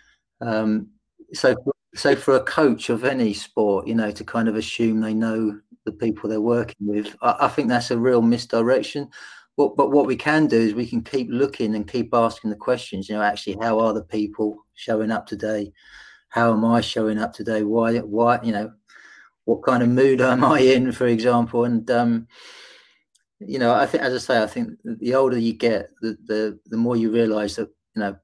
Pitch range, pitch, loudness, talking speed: 110-125 Hz, 115 Hz, -21 LUFS, 210 wpm